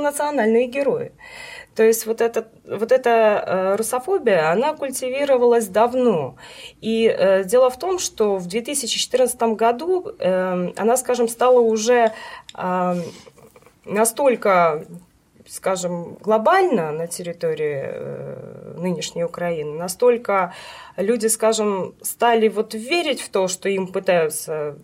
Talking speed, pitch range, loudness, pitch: 100 wpm, 190-255 Hz, -20 LUFS, 225 Hz